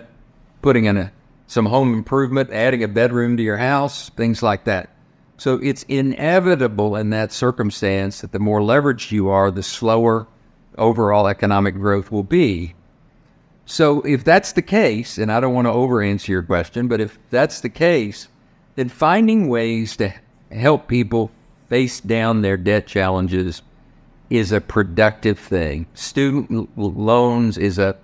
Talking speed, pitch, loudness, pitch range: 155 wpm, 115 Hz, -18 LUFS, 105-130 Hz